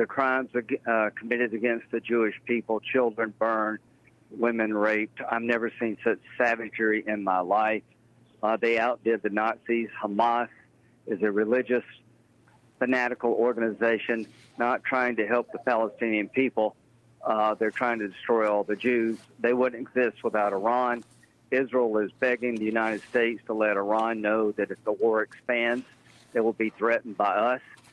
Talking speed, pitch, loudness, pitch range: 155 wpm, 115 Hz, -27 LUFS, 110-120 Hz